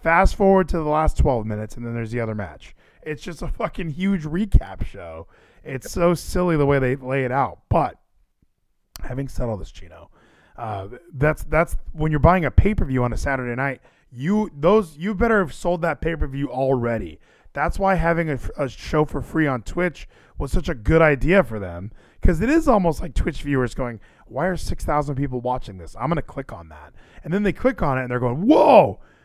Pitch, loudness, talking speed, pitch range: 145 Hz, -21 LUFS, 220 wpm, 120-175 Hz